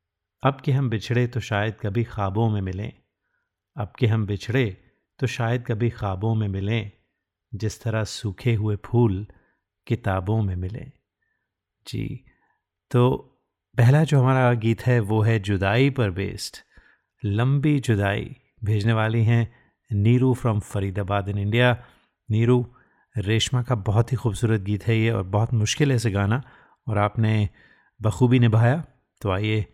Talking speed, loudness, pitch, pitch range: 145 wpm, -23 LUFS, 115 Hz, 105-125 Hz